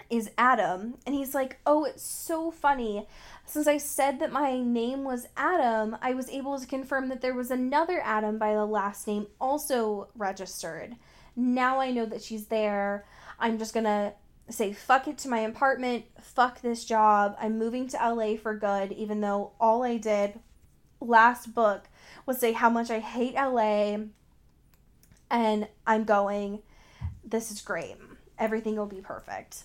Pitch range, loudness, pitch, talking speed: 210-260 Hz, -28 LUFS, 230 Hz, 165 wpm